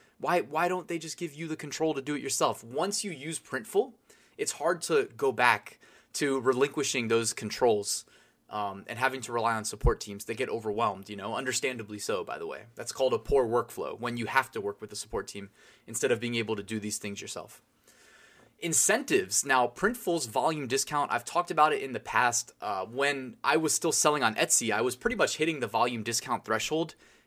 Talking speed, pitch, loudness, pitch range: 210 wpm, 135 Hz, -29 LUFS, 115-165 Hz